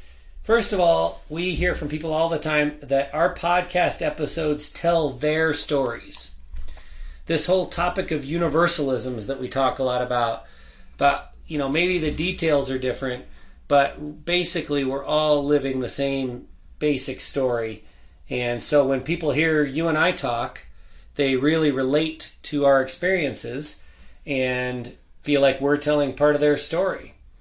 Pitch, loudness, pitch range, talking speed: 145 Hz, -23 LUFS, 125-160 Hz, 150 wpm